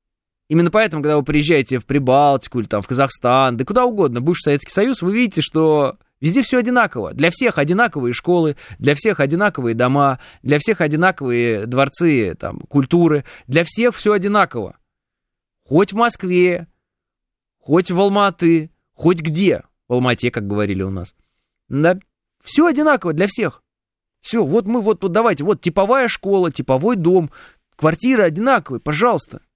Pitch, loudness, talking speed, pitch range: 165 Hz, -17 LUFS, 150 wpm, 135-205 Hz